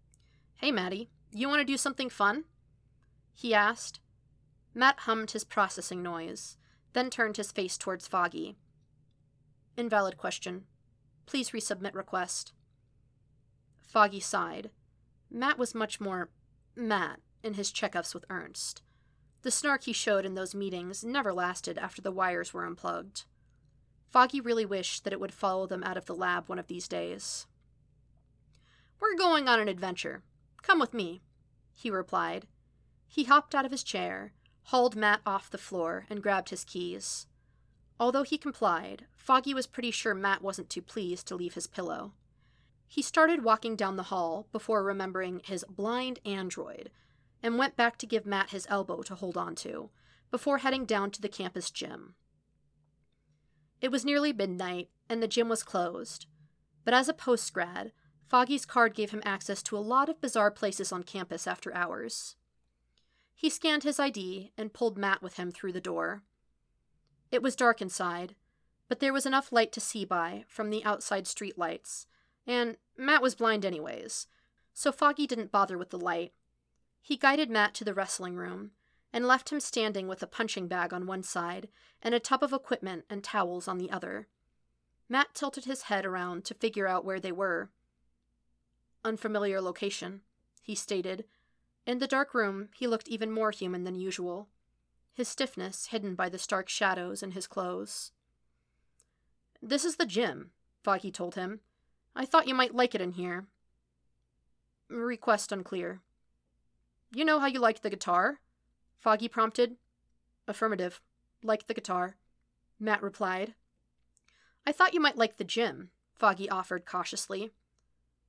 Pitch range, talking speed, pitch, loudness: 175-230 Hz, 160 wpm, 195 Hz, -31 LUFS